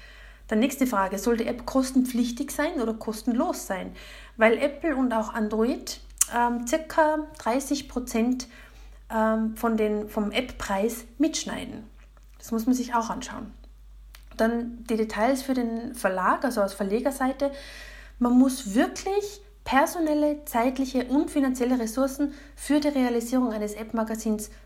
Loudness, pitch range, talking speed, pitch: -26 LUFS, 225-280 Hz, 130 wpm, 245 Hz